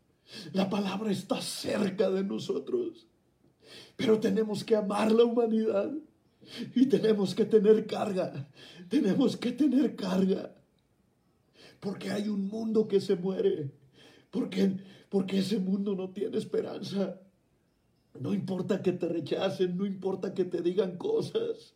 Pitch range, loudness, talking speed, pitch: 190-225 Hz, -30 LUFS, 125 wpm, 200 Hz